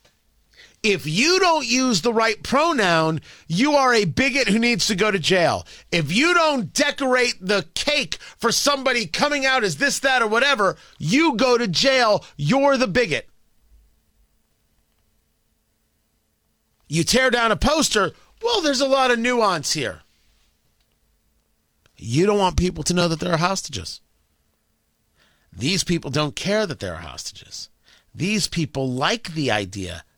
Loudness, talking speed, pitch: -20 LUFS, 145 wpm, 200 Hz